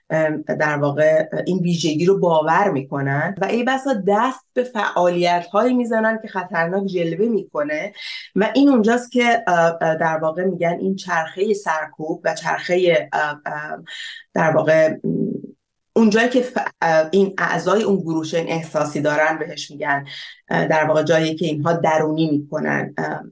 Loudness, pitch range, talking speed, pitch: -19 LUFS, 155-200 Hz, 130 wpm, 170 Hz